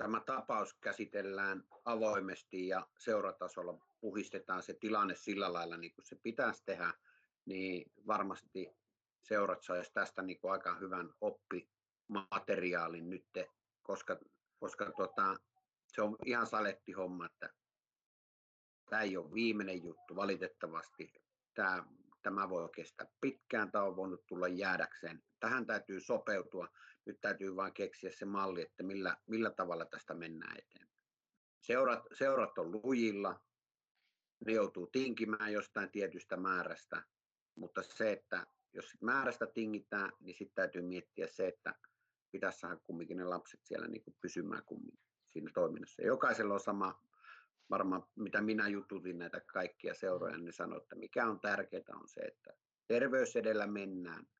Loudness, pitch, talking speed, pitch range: -40 LUFS, 100 Hz, 135 wpm, 90-120 Hz